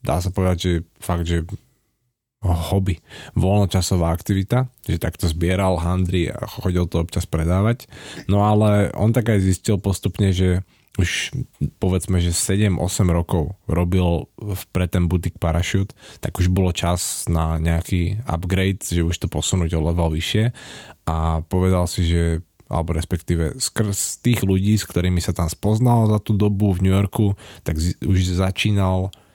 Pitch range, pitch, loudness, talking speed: 85-105 Hz, 95 Hz, -21 LUFS, 150 wpm